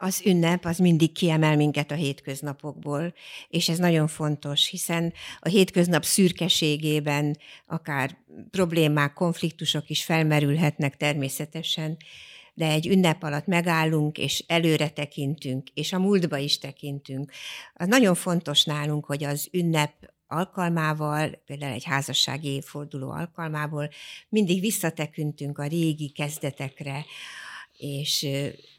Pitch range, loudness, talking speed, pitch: 145-170 Hz, -25 LUFS, 115 wpm, 150 Hz